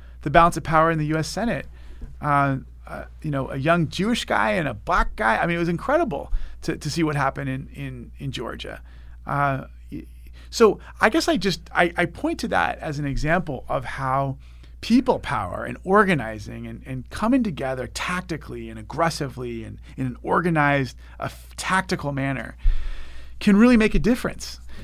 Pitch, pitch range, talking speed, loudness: 140 Hz, 110-170 Hz, 175 wpm, -23 LUFS